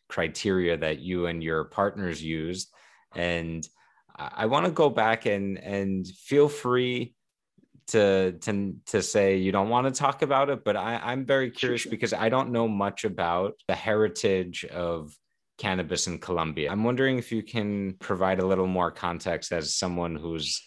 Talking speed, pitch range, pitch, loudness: 170 wpm, 85-115 Hz, 95 Hz, -27 LUFS